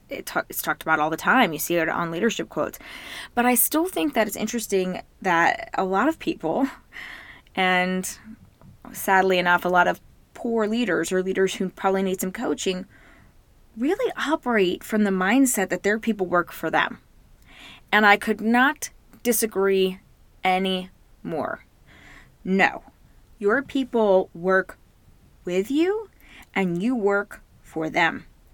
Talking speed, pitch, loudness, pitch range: 145 wpm, 200 Hz, -23 LUFS, 185-240 Hz